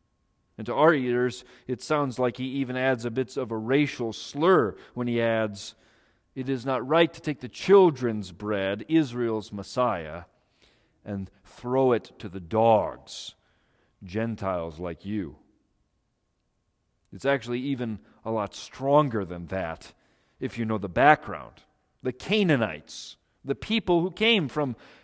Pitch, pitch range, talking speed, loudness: 120 Hz, 105-135 Hz, 140 wpm, -26 LUFS